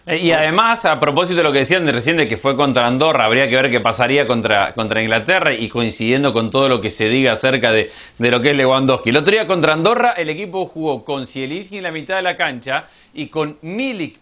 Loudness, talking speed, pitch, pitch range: -16 LUFS, 240 wpm, 145 Hz, 125-170 Hz